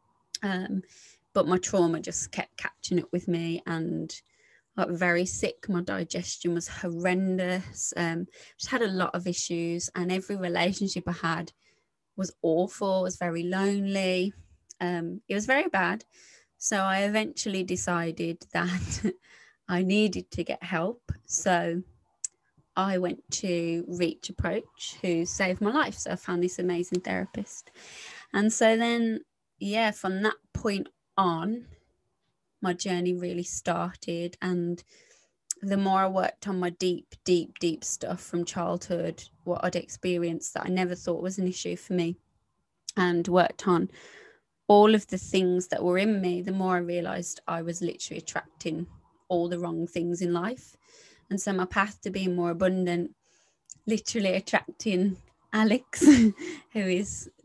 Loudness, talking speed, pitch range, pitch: -28 LUFS, 150 wpm, 175-195 Hz, 180 Hz